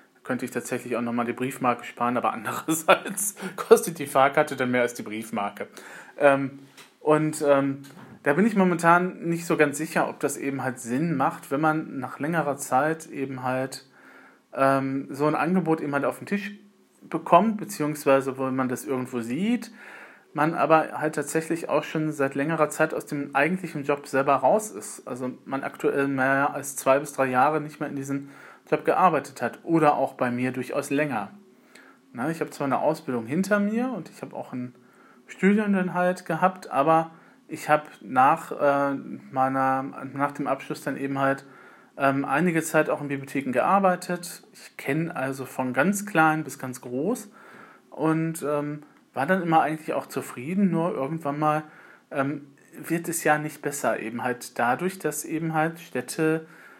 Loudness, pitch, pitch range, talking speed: -25 LUFS, 150 Hz, 135-165 Hz, 170 wpm